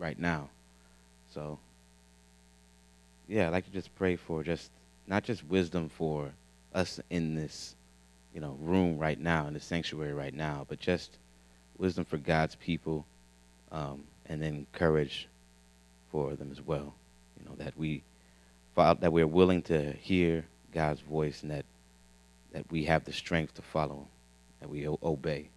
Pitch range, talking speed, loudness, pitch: 60-80 Hz, 155 wpm, -33 LUFS, 75 Hz